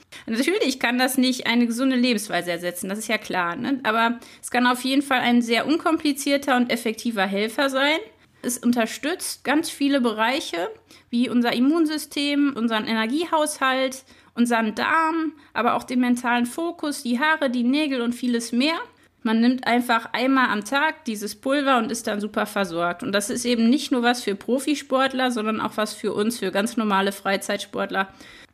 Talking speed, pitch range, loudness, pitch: 170 wpm, 225-275 Hz, -22 LUFS, 245 Hz